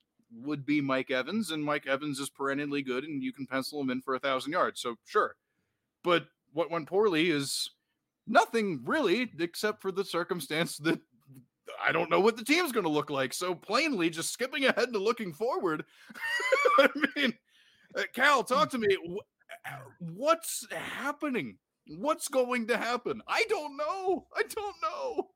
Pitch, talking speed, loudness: 200 Hz, 165 wpm, -30 LUFS